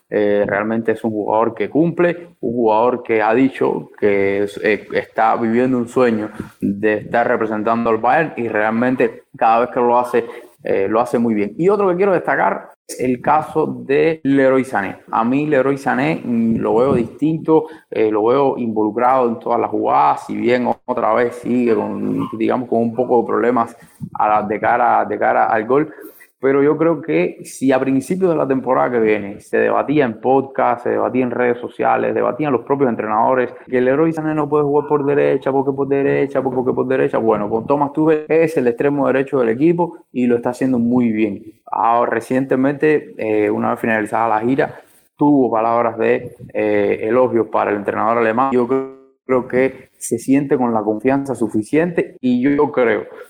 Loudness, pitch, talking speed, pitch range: -17 LUFS, 125 Hz, 190 wpm, 115-145 Hz